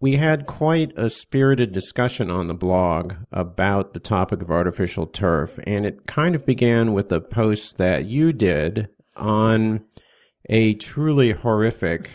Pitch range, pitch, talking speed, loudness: 90-125 Hz, 110 Hz, 150 wpm, -21 LUFS